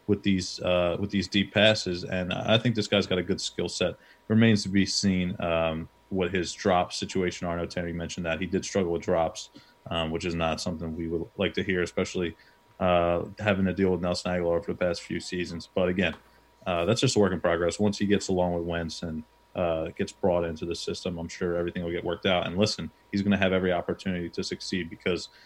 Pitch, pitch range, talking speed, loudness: 90 Hz, 85-100 Hz, 235 wpm, -27 LUFS